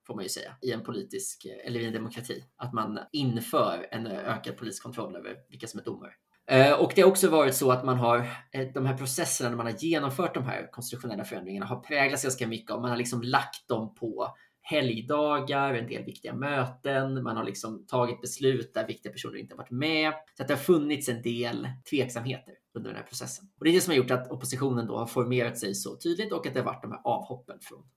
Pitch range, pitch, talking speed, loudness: 120-145 Hz, 130 Hz, 230 wpm, -29 LUFS